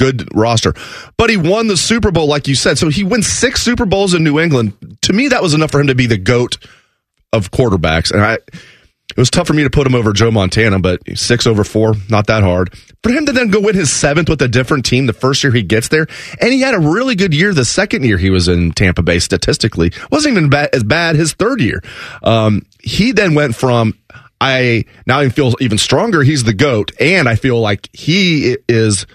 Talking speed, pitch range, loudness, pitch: 235 wpm, 110-160 Hz, -12 LUFS, 130 Hz